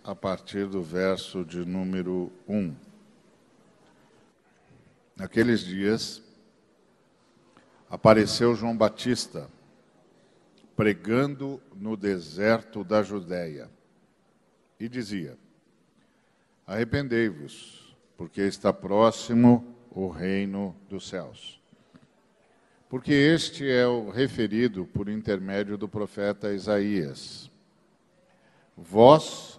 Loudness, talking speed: -26 LUFS, 75 wpm